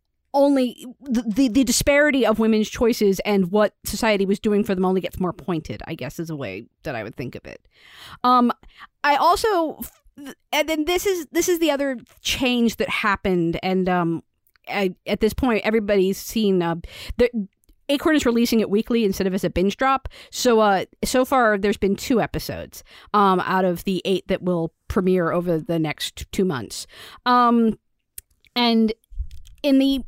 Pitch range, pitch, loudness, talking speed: 185-255 Hz, 215 Hz, -21 LUFS, 180 wpm